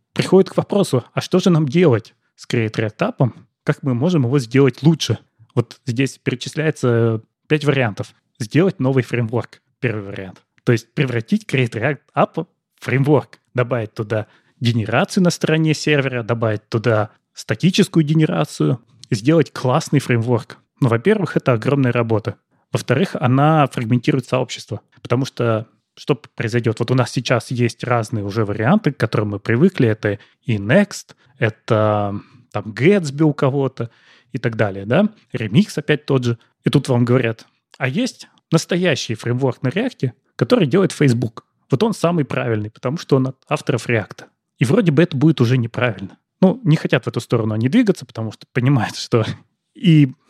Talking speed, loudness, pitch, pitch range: 160 wpm, -18 LUFS, 130 Hz, 120-155 Hz